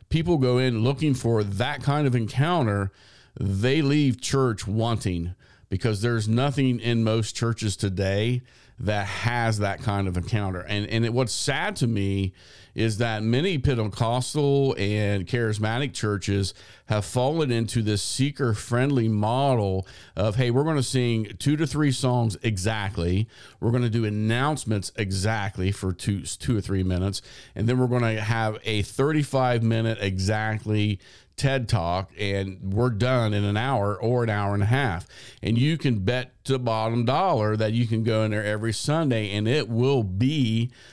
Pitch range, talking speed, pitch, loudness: 105-125 Hz, 165 wpm, 115 Hz, -25 LUFS